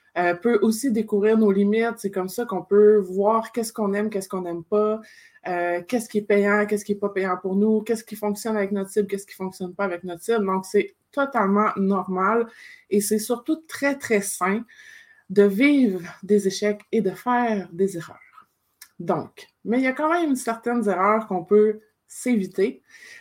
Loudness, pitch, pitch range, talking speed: -23 LUFS, 210 Hz, 195-230 Hz, 195 wpm